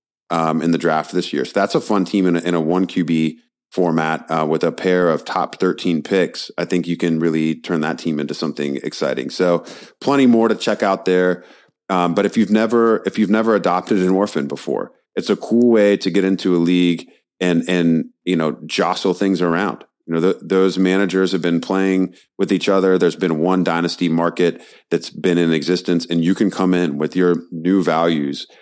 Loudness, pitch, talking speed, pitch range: -18 LUFS, 90 Hz, 210 wpm, 85-95 Hz